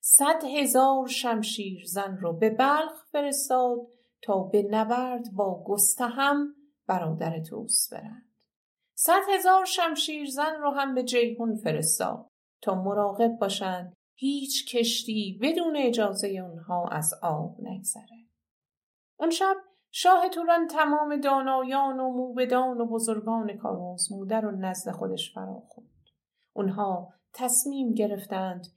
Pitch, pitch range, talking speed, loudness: 235 Hz, 200-280 Hz, 115 wpm, -26 LUFS